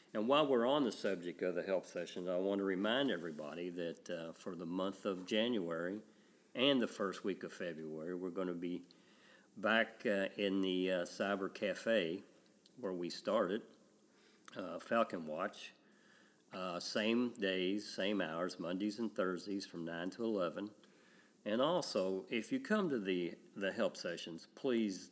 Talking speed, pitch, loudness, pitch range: 160 wpm, 95 Hz, -39 LUFS, 90-105 Hz